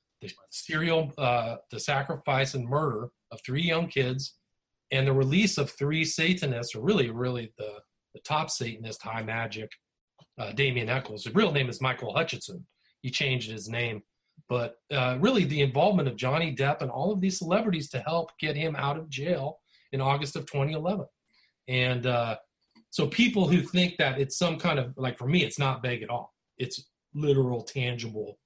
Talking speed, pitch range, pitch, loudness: 180 wpm, 125-160 Hz, 135 Hz, -28 LUFS